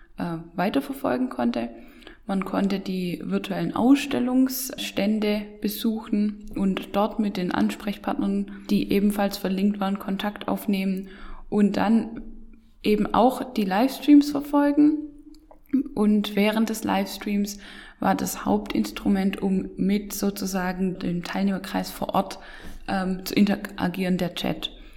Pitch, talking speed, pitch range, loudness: 205 Hz, 110 wpm, 190-235 Hz, -25 LUFS